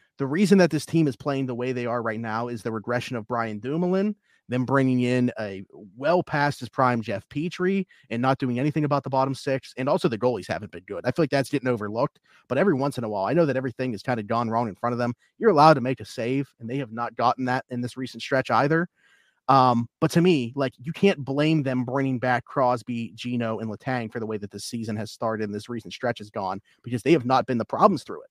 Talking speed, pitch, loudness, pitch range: 265 wpm, 125 Hz, -25 LUFS, 115-140 Hz